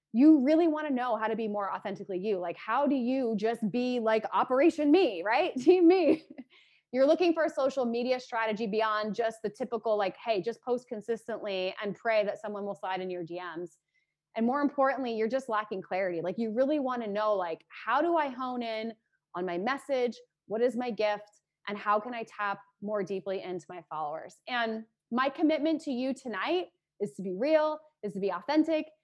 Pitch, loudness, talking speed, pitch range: 230 Hz, -30 LUFS, 200 wpm, 205-270 Hz